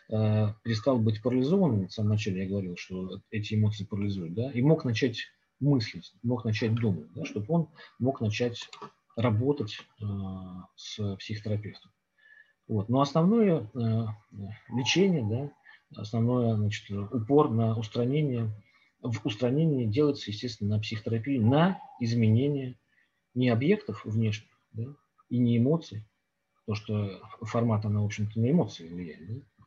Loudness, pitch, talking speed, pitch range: -29 LUFS, 115 Hz, 130 wpm, 105-135 Hz